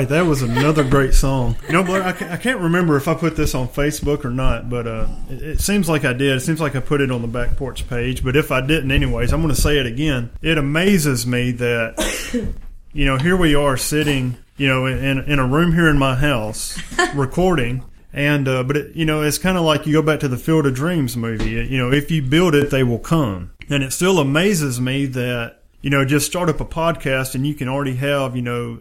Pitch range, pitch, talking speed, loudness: 130-155 Hz, 140 Hz, 250 wpm, -18 LUFS